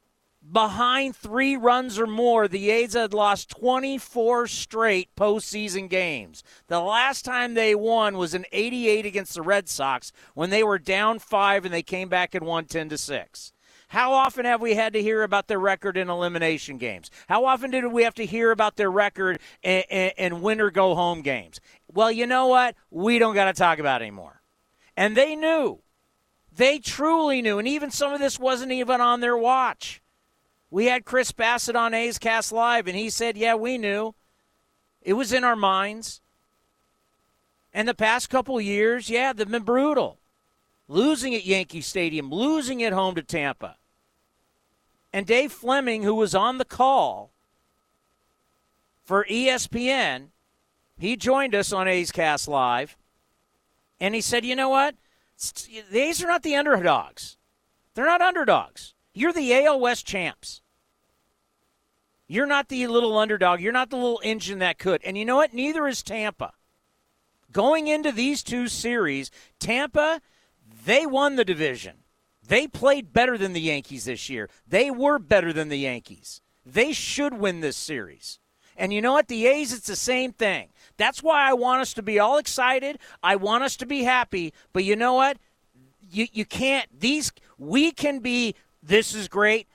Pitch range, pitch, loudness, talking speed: 185-255 Hz, 225 Hz, -23 LUFS, 170 wpm